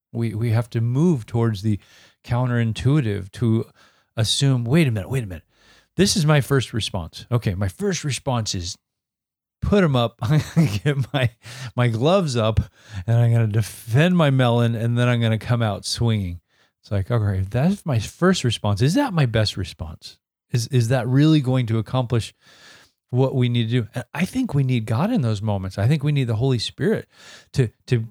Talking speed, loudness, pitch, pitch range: 190 wpm, -21 LUFS, 120 Hz, 110-135 Hz